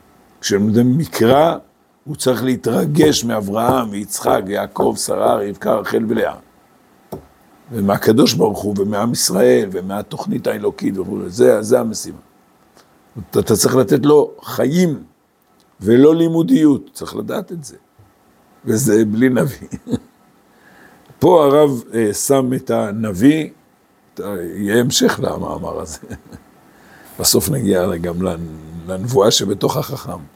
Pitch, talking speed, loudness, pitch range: 120 Hz, 105 wpm, -16 LUFS, 100-150 Hz